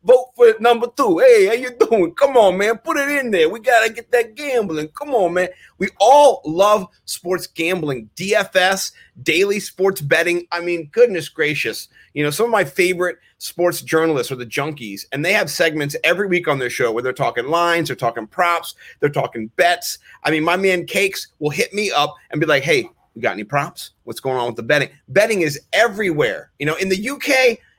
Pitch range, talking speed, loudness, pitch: 155-230 Hz, 210 wpm, -17 LUFS, 180 Hz